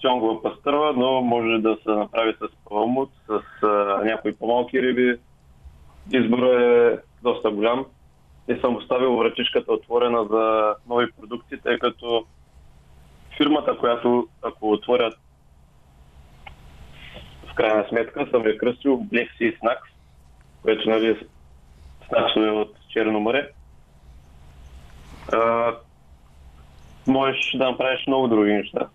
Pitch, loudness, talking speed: 110 Hz, -22 LUFS, 110 wpm